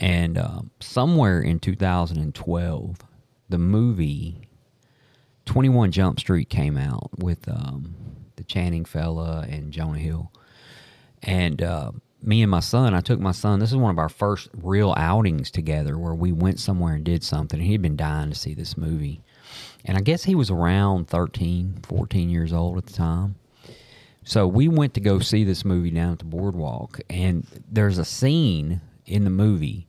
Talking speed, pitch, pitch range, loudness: 175 wpm, 95 Hz, 85-115 Hz, -23 LUFS